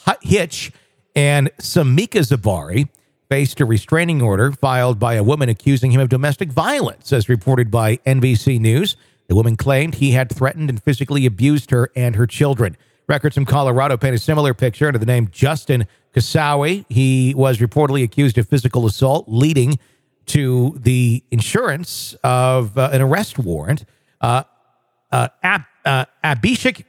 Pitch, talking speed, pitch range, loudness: 130 Hz, 150 wpm, 125-145 Hz, -17 LUFS